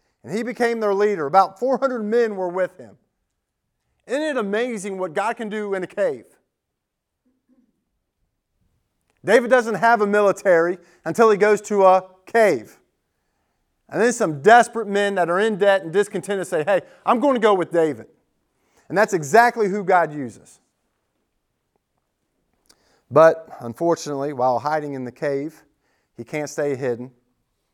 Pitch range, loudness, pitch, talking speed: 155-225 Hz, -20 LUFS, 195 Hz, 145 wpm